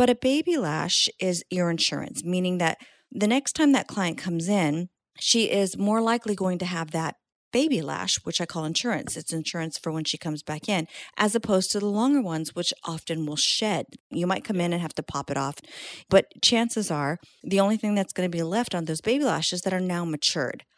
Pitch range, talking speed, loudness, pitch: 160-210 Hz, 220 wpm, -25 LUFS, 180 Hz